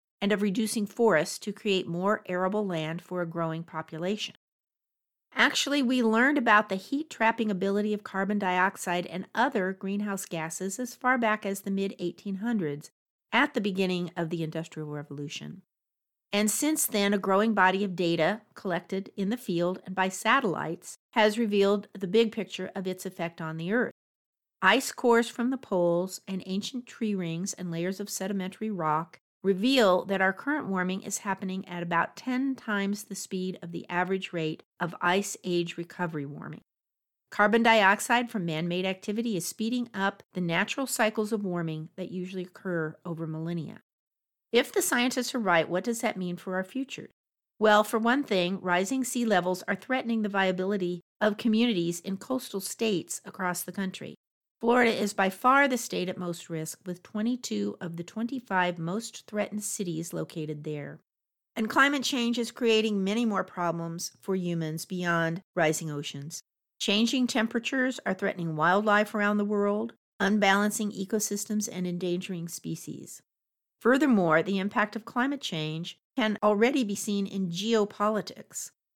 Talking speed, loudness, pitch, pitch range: 160 wpm, -28 LUFS, 195 Hz, 180-220 Hz